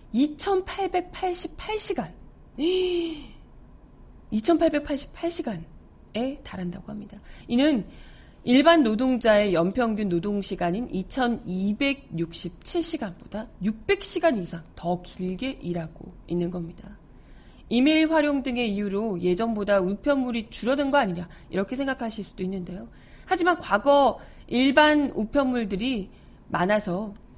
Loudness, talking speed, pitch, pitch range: -25 LUFS, 220 characters per minute, 225 Hz, 190-285 Hz